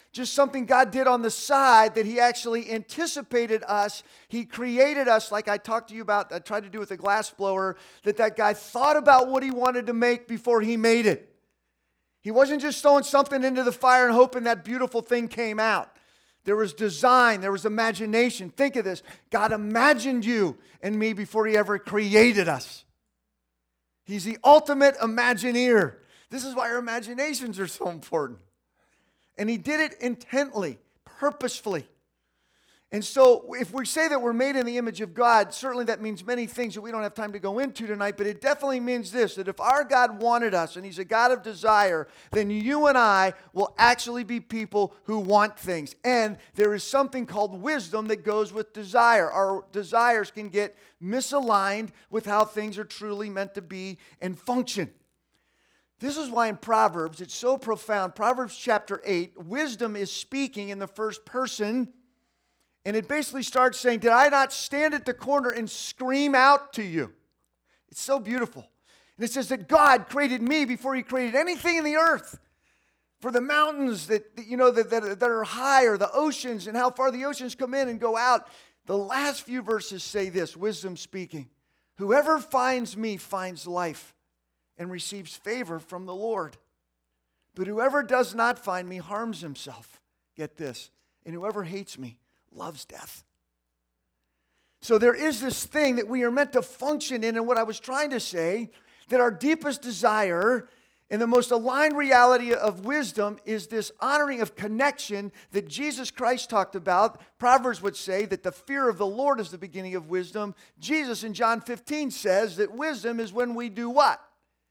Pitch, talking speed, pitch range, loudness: 230 Hz, 185 wpm, 205-255 Hz, -25 LUFS